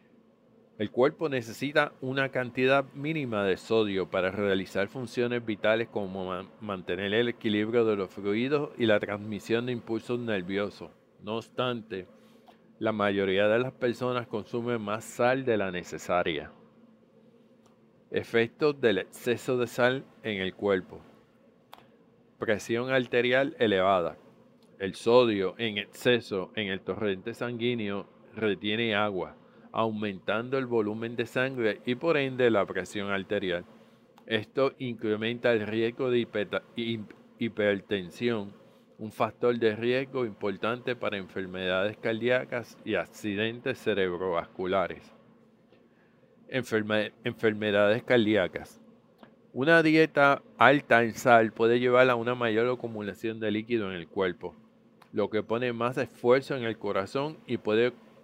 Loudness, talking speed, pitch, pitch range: -28 LUFS, 120 wpm, 115 Hz, 105-125 Hz